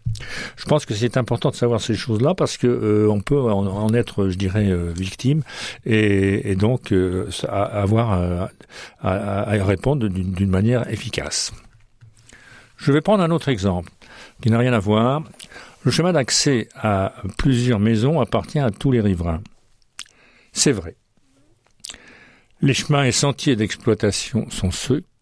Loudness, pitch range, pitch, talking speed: -20 LUFS, 100-125 Hz, 110 Hz, 150 wpm